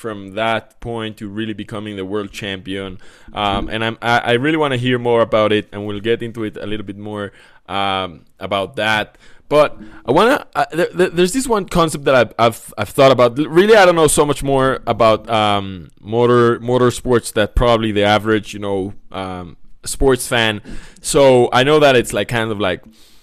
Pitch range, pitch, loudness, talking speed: 105-125 Hz, 110 Hz, -16 LUFS, 200 wpm